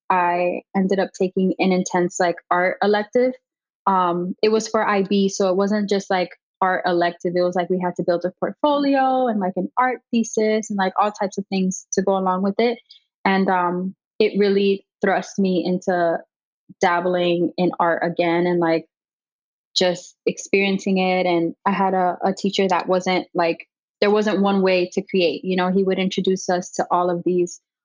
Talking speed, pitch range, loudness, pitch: 185 wpm, 180-200 Hz, -20 LUFS, 185 Hz